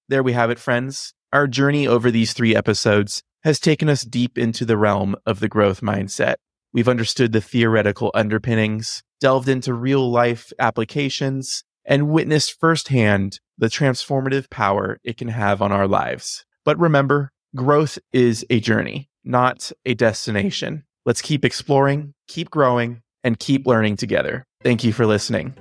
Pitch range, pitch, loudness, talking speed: 110-140 Hz, 120 Hz, -19 LUFS, 155 wpm